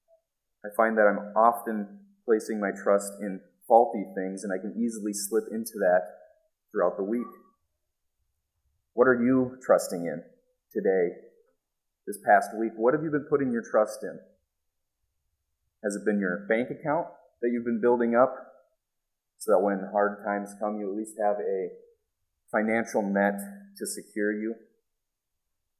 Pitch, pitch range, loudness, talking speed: 105 Hz, 95-120 Hz, -27 LUFS, 150 wpm